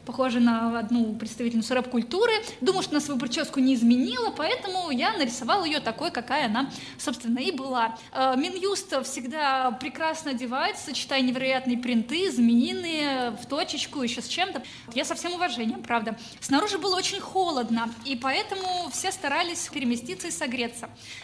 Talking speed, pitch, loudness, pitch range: 145 wpm, 265 Hz, -26 LUFS, 240-335 Hz